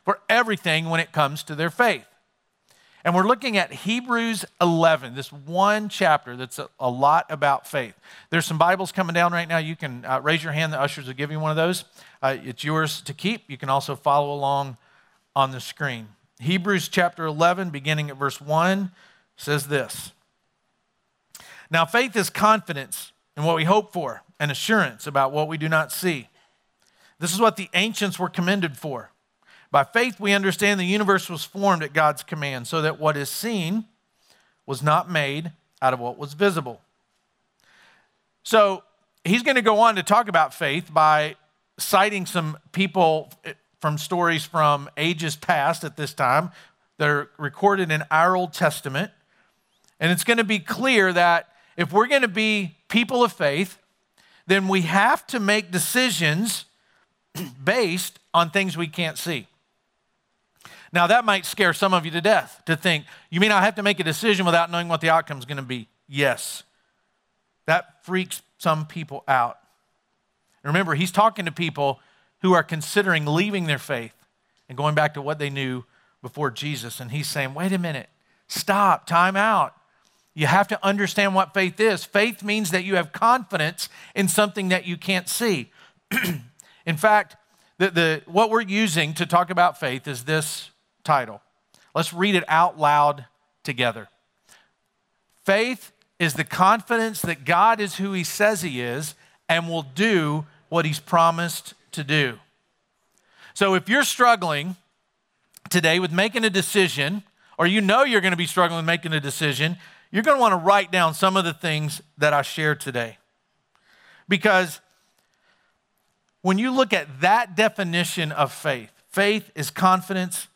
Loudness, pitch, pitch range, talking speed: -22 LUFS, 170 Hz, 150-195 Hz, 170 wpm